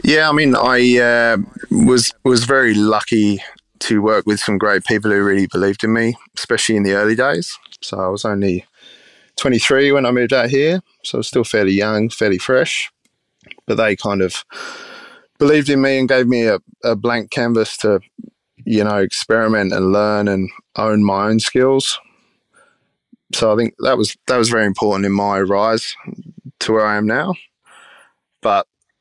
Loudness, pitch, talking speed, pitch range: -16 LUFS, 110 Hz, 180 wpm, 105-125 Hz